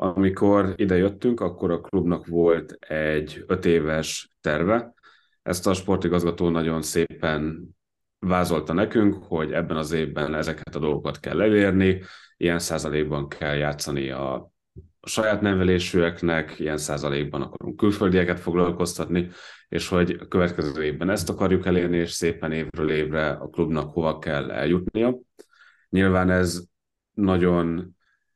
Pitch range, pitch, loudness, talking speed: 80-95 Hz, 85 Hz, -24 LUFS, 125 wpm